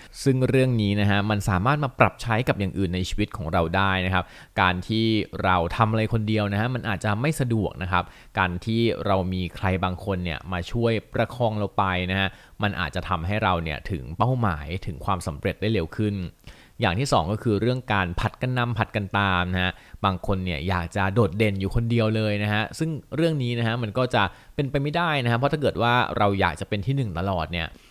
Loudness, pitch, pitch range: -24 LUFS, 105 Hz, 95-115 Hz